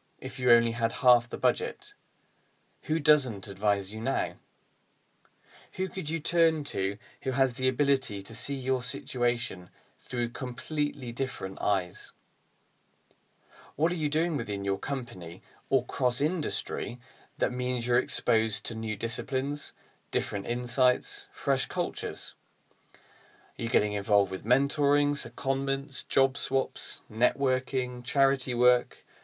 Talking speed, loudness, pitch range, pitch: 125 wpm, -29 LUFS, 115-140 Hz, 130 Hz